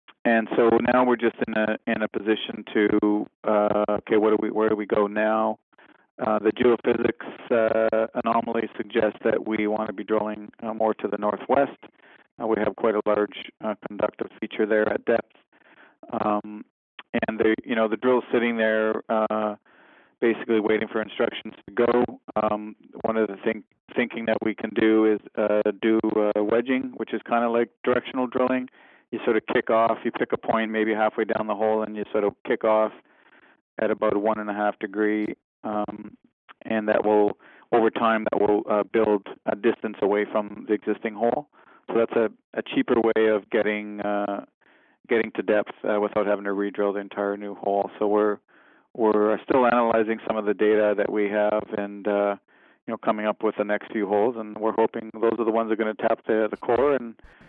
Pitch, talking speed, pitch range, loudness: 110 Hz, 200 wpm, 105-115 Hz, -24 LUFS